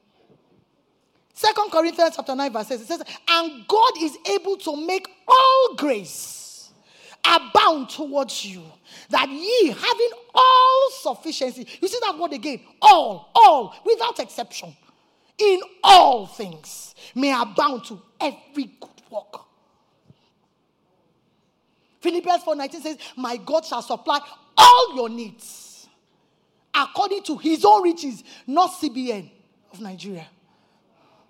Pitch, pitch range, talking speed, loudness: 305 Hz, 240-390 Hz, 120 wpm, -19 LUFS